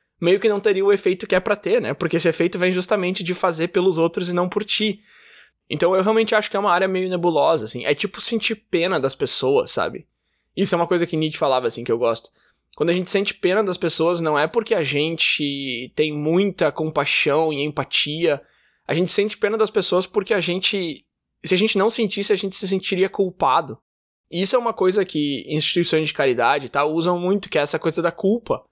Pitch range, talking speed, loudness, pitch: 160-200 Hz, 225 wpm, -20 LUFS, 180 Hz